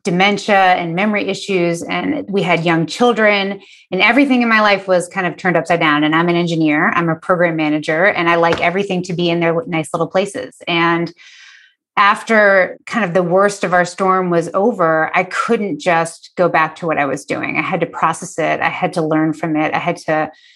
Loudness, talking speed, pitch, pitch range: -15 LUFS, 215 wpm, 175 Hz, 165-195 Hz